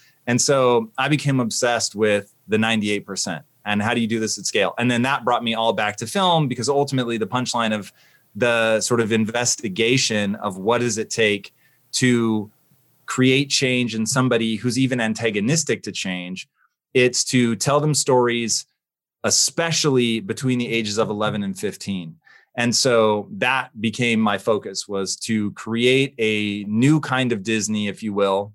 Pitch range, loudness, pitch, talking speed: 105-125 Hz, -20 LUFS, 115 Hz, 165 wpm